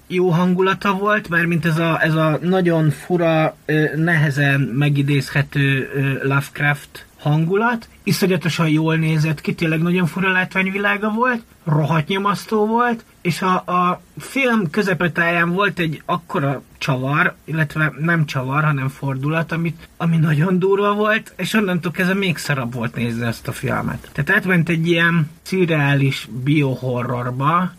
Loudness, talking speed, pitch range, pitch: -18 LUFS, 135 wpm, 145-185 Hz, 165 Hz